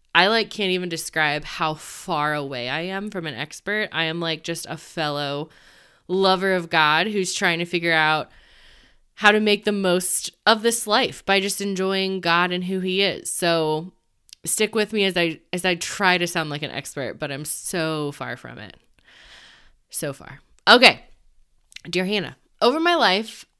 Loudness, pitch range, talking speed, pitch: -21 LUFS, 155-195 Hz, 180 wpm, 175 Hz